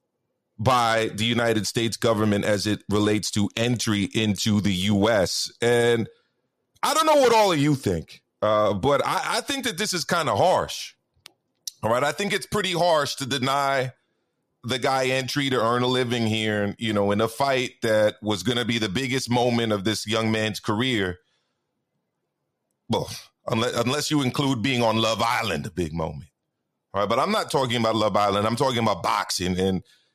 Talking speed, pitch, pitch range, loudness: 190 wpm, 115 Hz, 105-135 Hz, -23 LUFS